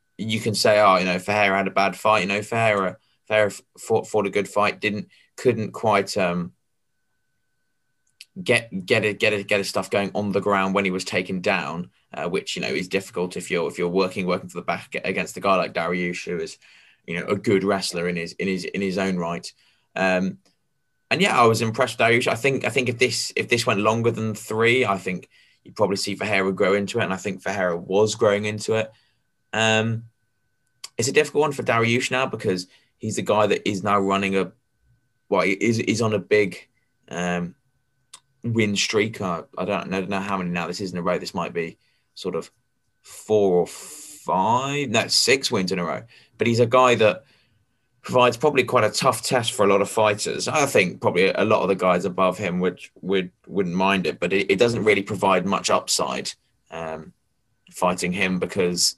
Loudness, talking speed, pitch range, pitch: -22 LUFS, 215 wpm, 95-115 Hz, 105 Hz